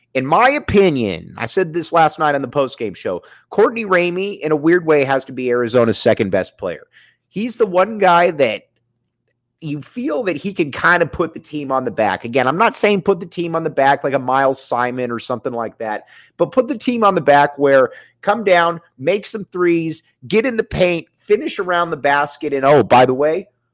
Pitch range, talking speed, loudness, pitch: 135-195 Hz, 220 wpm, -16 LUFS, 160 Hz